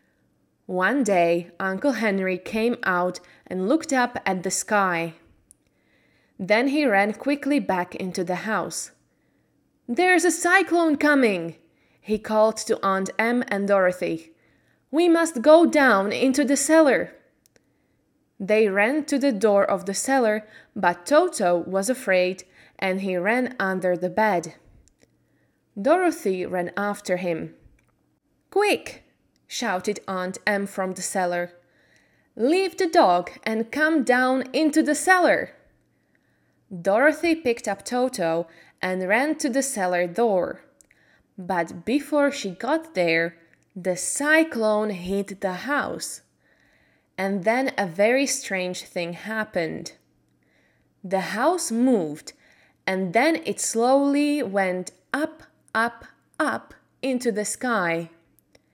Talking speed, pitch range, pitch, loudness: 120 wpm, 185-275 Hz, 210 Hz, -23 LUFS